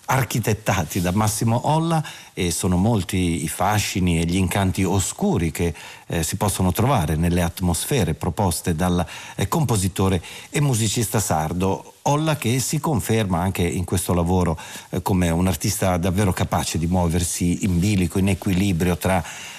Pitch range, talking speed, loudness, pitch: 90-110 Hz, 145 wpm, -21 LUFS, 95 Hz